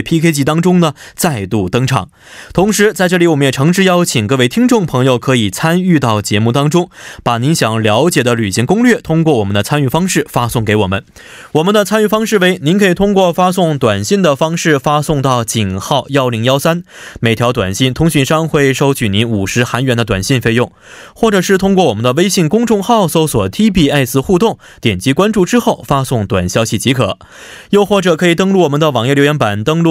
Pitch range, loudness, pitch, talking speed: 120-180 Hz, -12 LUFS, 145 Hz, 320 characters per minute